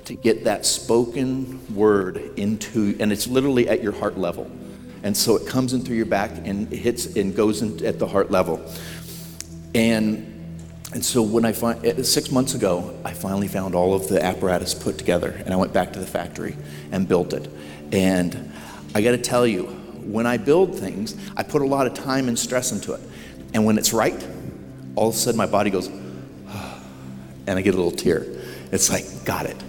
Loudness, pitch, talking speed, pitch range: -22 LUFS, 105 Hz, 200 wpm, 80-120 Hz